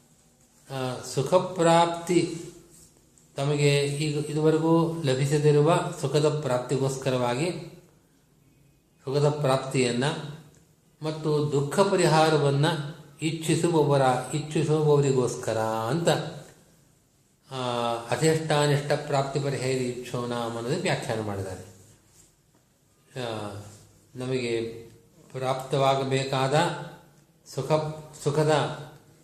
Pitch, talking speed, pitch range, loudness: 145 Hz, 50 wpm, 130-160 Hz, -25 LUFS